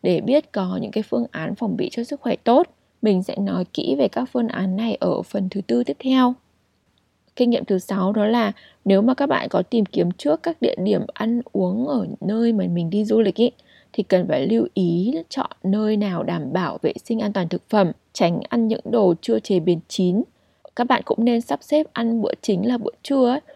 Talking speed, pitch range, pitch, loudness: 230 wpm, 190-240 Hz, 215 Hz, -21 LUFS